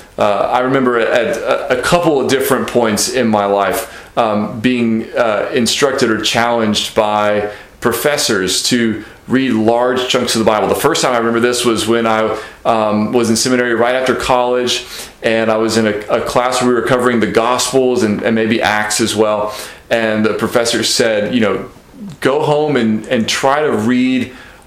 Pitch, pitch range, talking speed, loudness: 115 Hz, 110-125 Hz, 180 wpm, -14 LUFS